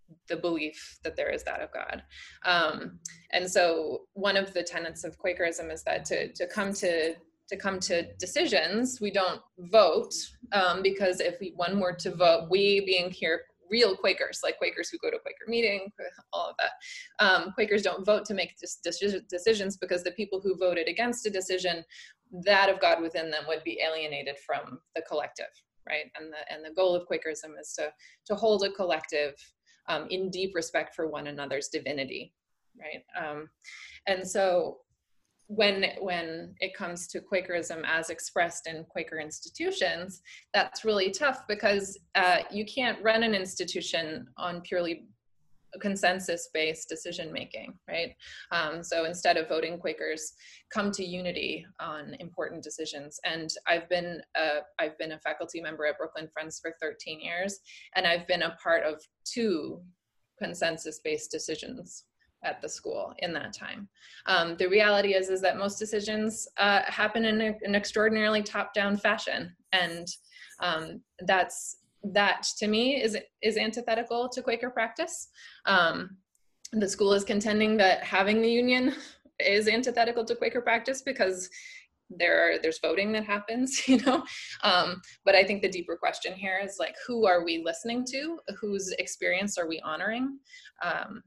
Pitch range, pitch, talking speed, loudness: 170-215 Hz, 190 Hz, 160 wpm, -29 LUFS